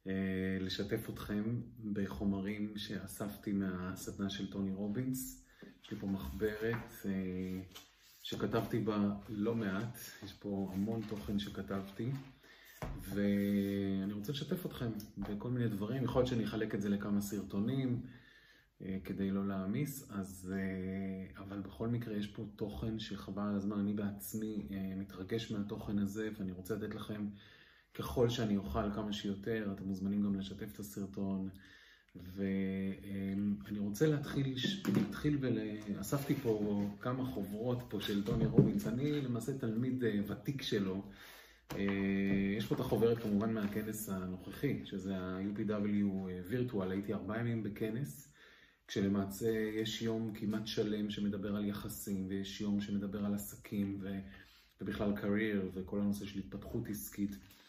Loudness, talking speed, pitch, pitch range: -38 LUFS, 125 wpm, 100 Hz, 100-110 Hz